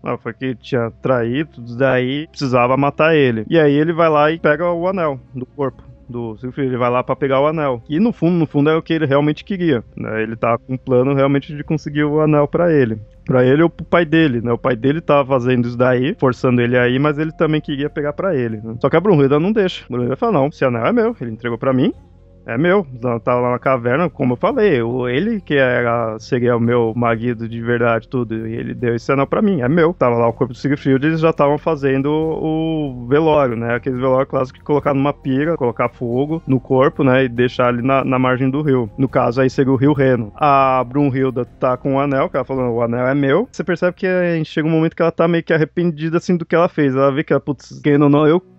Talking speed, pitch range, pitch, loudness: 255 wpm, 125-155 Hz, 135 Hz, -17 LUFS